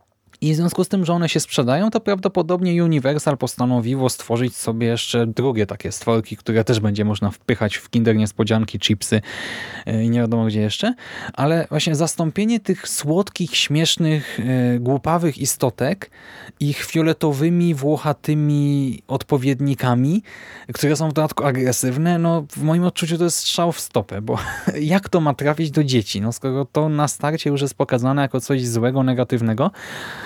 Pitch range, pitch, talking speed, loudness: 120-160 Hz, 140 Hz, 155 wpm, -20 LUFS